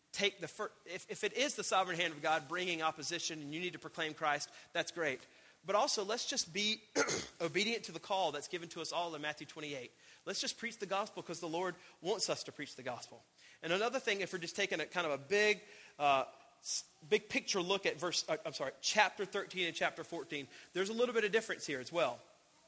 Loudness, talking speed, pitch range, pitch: -37 LUFS, 235 wpm, 160-210 Hz, 180 Hz